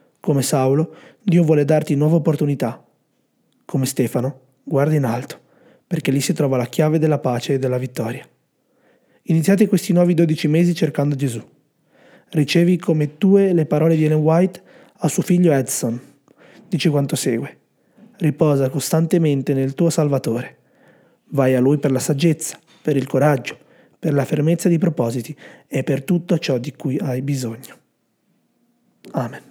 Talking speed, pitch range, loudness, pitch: 150 wpm, 135-170 Hz, -19 LUFS, 150 Hz